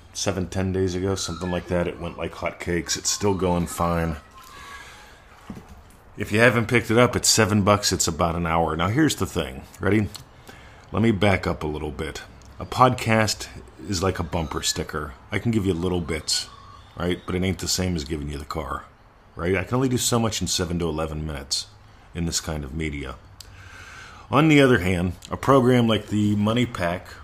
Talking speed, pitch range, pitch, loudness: 205 wpm, 85-105 Hz, 95 Hz, -23 LUFS